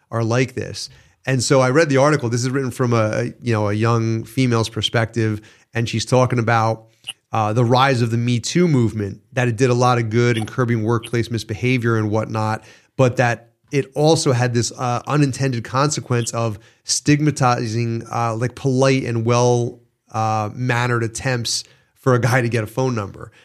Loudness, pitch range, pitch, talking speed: -19 LUFS, 115-130 Hz, 120 Hz, 185 wpm